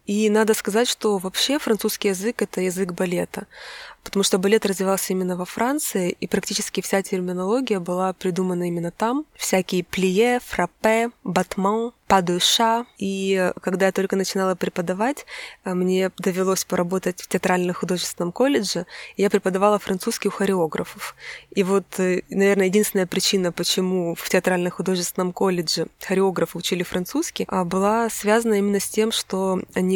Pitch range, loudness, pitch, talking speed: 185-215 Hz, -22 LUFS, 195 Hz, 140 wpm